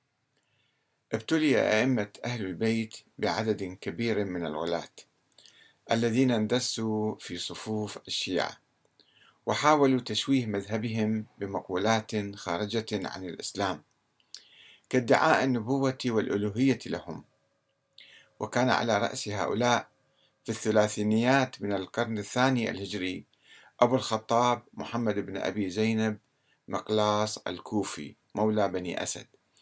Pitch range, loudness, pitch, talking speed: 105-125 Hz, -29 LUFS, 110 Hz, 90 wpm